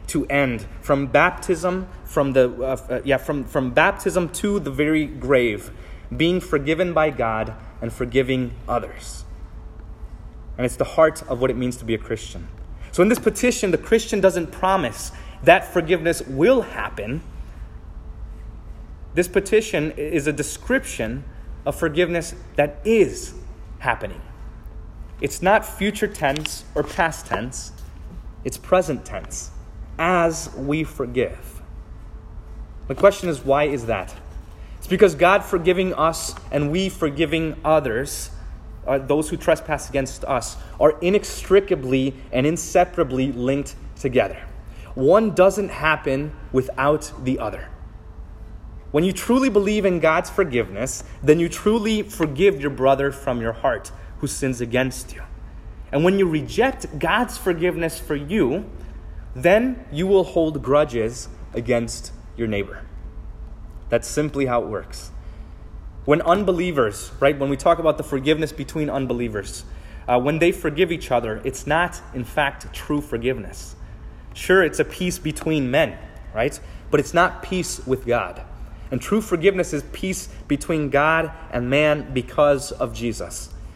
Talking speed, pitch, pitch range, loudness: 135 wpm, 145 Hz, 115-170 Hz, -21 LUFS